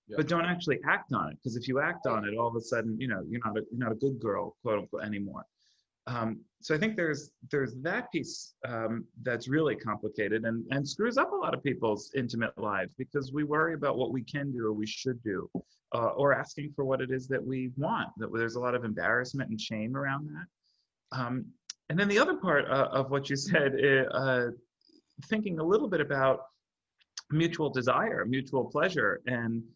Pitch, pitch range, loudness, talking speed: 130 Hz, 115-150 Hz, -31 LUFS, 210 wpm